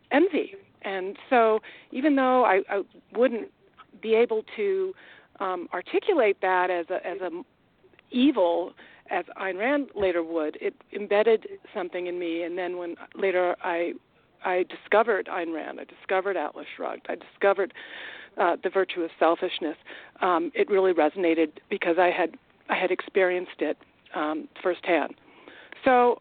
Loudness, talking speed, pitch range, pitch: -26 LUFS, 145 wpm, 175-255 Hz, 190 Hz